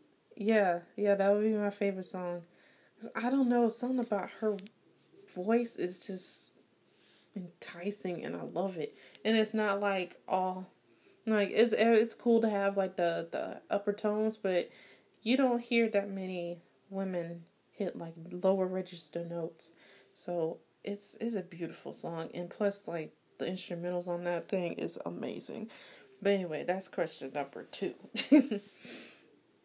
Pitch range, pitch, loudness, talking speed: 175-220 Hz, 195 Hz, -33 LUFS, 145 wpm